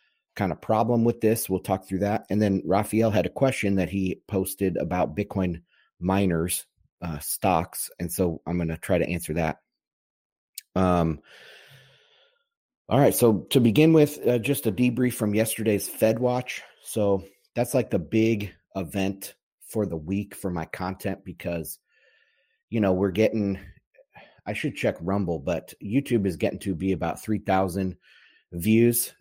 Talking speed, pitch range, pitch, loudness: 160 wpm, 90-115 Hz, 100 Hz, -25 LUFS